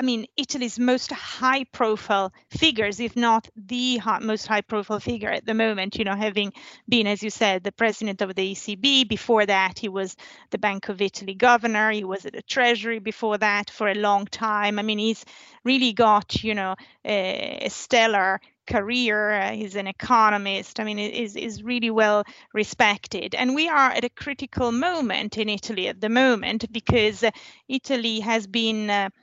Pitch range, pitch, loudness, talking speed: 205-240 Hz, 220 Hz, -23 LUFS, 175 wpm